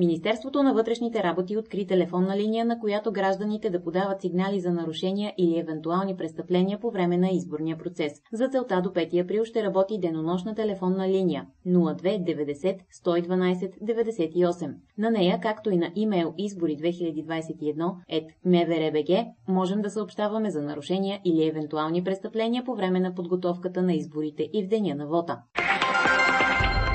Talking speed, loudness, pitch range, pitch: 145 wpm, -26 LUFS, 165-205 Hz, 180 Hz